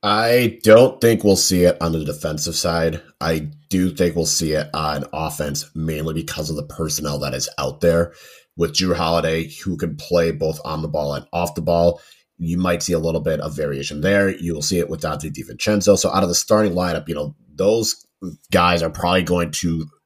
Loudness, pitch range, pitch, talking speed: -19 LUFS, 75-90 Hz, 85 Hz, 210 wpm